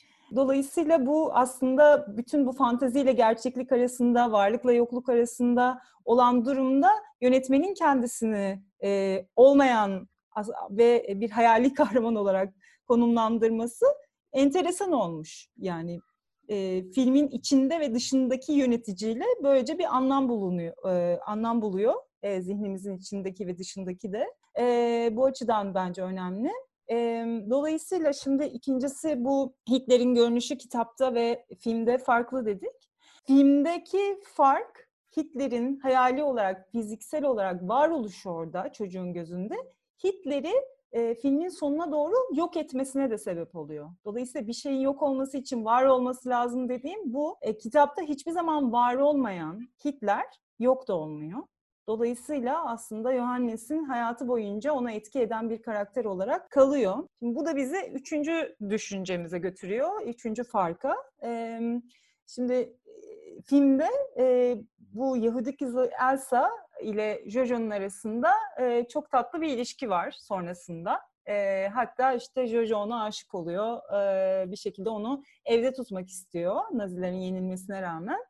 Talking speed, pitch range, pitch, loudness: 115 wpm, 215-275 Hz, 245 Hz, -27 LUFS